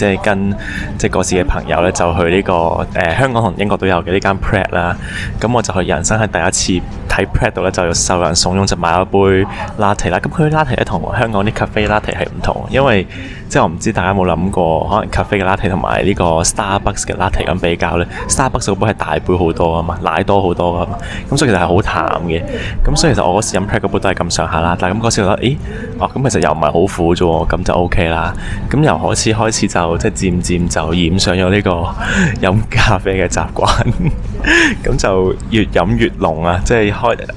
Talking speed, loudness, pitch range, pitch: 395 characters per minute, -14 LUFS, 90-105 Hz, 95 Hz